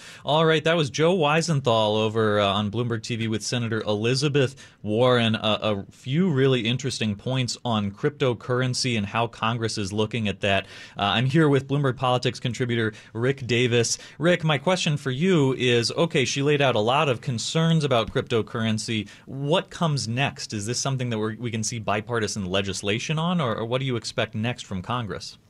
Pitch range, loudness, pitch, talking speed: 110-140 Hz, -24 LUFS, 120 Hz, 180 wpm